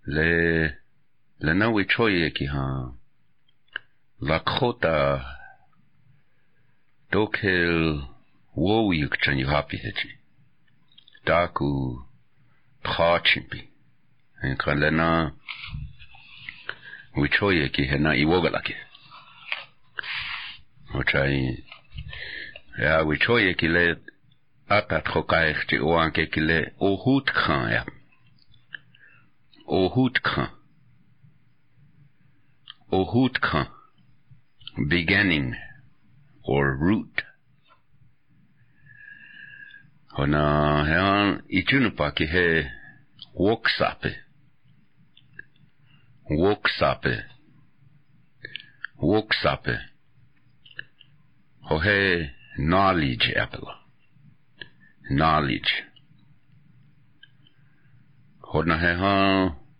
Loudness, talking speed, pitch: -23 LUFS, 60 wpm, 90 Hz